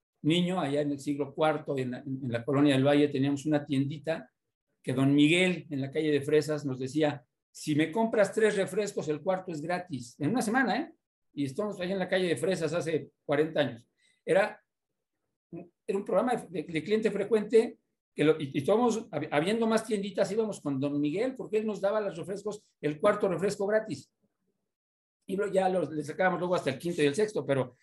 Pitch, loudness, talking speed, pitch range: 165 Hz, -29 LUFS, 200 wpm, 145-205 Hz